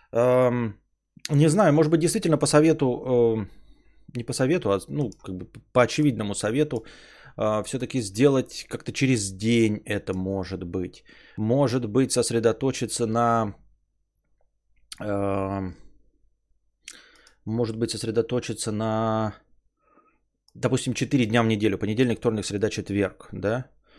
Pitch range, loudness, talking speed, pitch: 100-130 Hz, -24 LUFS, 110 wpm, 115 Hz